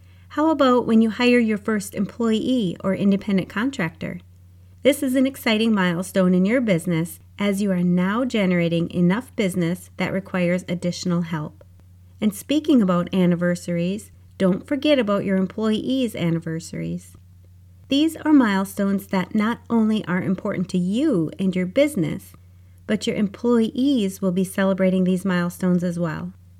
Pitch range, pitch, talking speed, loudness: 175-225 Hz, 190 Hz, 140 wpm, -21 LUFS